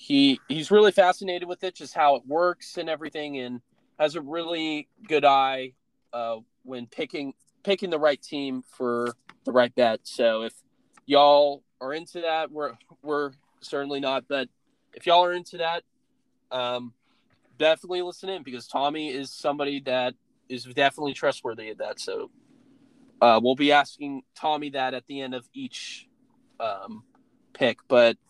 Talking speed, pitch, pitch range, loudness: 155 wpm, 145 Hz, 135-180 Hz, -25 LUFS